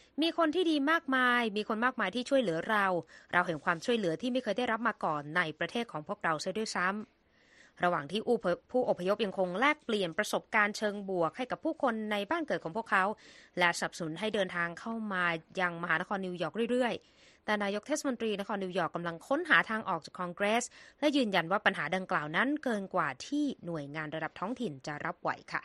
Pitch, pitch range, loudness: 200 Hz, 175-235 Hz, -32 LUFS